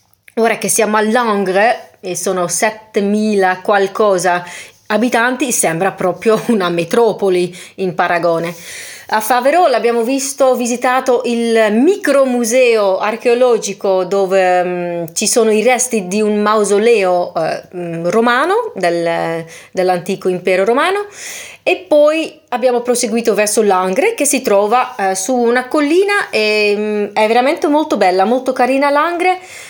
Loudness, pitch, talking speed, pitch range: -14 LUFS, 220 Hz, 125 wpm, 190-250 Hz